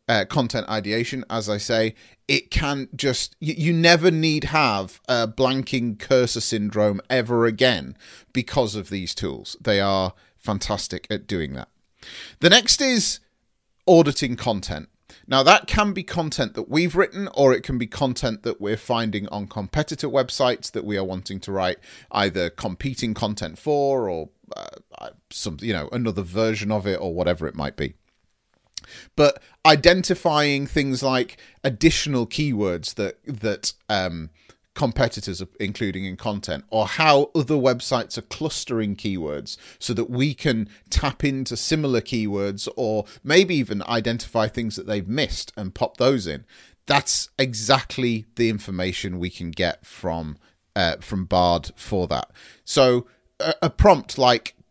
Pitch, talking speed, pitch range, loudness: 115 Hz, 150 wpm, 100-140 Hz, -22 LUFS